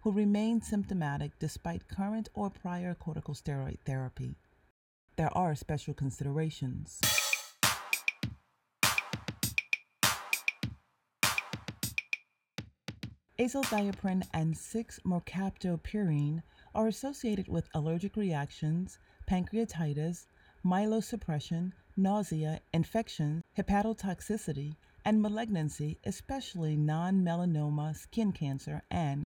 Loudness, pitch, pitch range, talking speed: -34 LUFS, 170 Hz, 150-205 Hz, 70 wpm